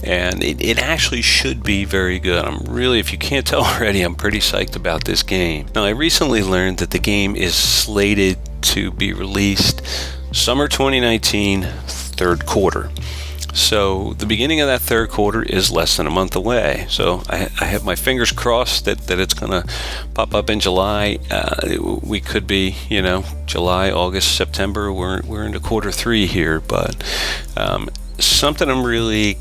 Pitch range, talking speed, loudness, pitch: 75-105 Hz, 180 wpm, -17 LUFS, 95 Hz